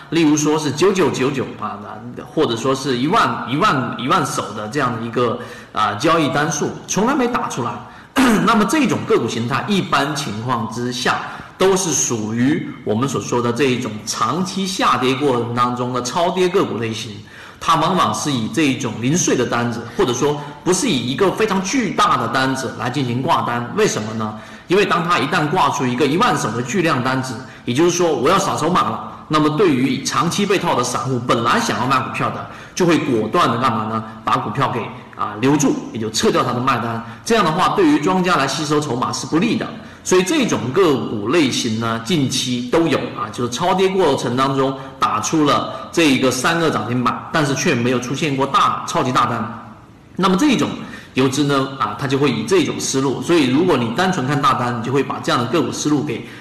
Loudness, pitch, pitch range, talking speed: -18 LUFS, 130 Hz, 120-160 Hz, 305 characters per minute